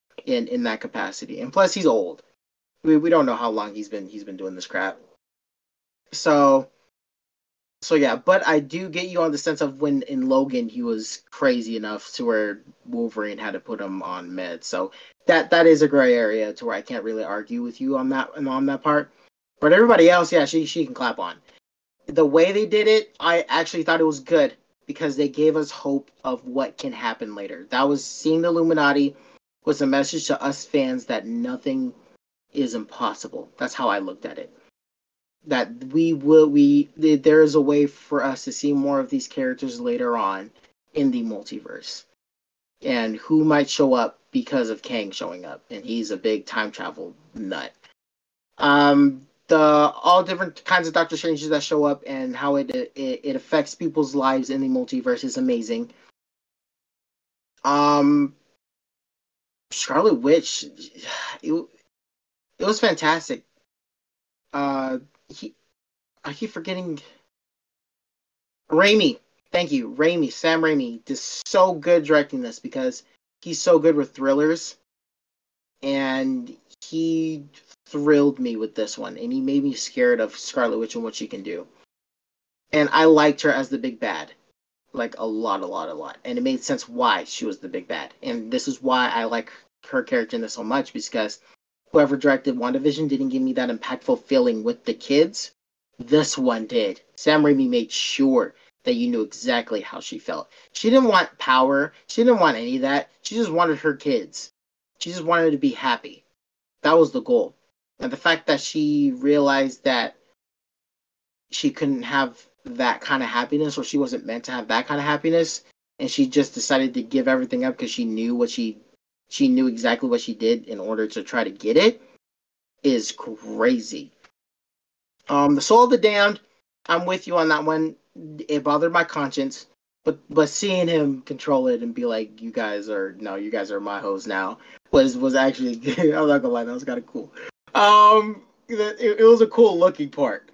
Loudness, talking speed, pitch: -21 LUFS, 185 wpm, 160 Hz